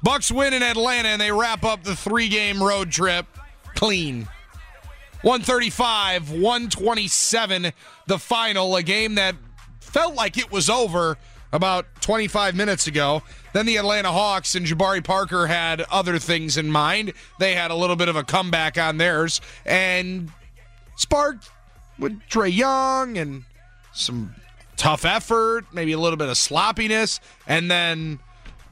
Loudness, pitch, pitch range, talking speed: -21 LUFS, 185 Hz, 160-220 Hz, 140 wpm